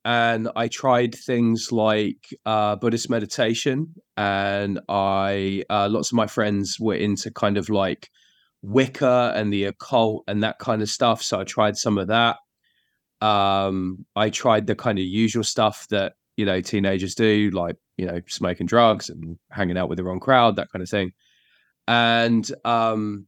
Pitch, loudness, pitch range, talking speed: 105 Hz, -22 LUFS, 100-115 Hz, 170 wpm